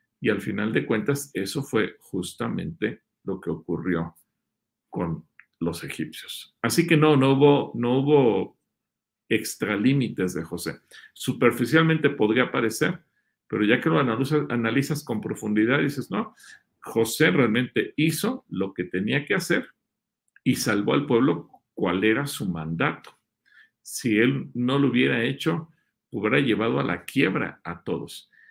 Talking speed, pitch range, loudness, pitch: 140 wpm, 95-145 Hz, -24 LUFS, 125 Hz